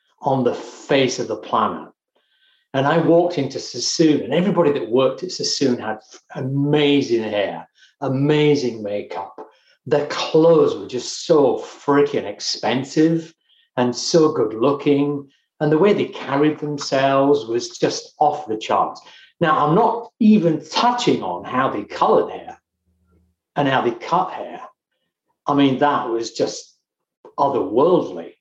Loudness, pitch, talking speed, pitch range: -19 LUFS, 145 Hz, 140 wpm, 130-175 Hz